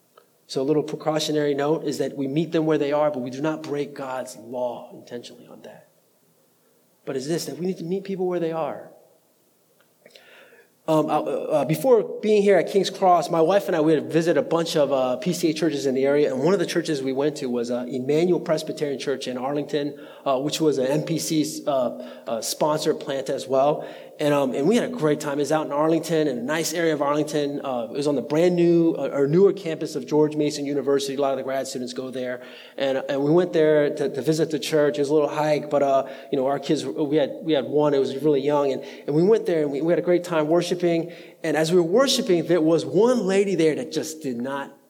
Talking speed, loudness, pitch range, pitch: 245 wpm, -23 LUFS, 140-165 Hz, 150 Hz